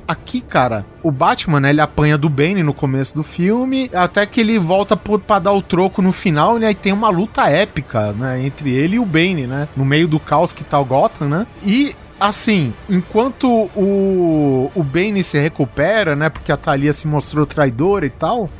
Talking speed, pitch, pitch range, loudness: 205 wpm, 165 Hz, 145-200 Hz, -16 LUFS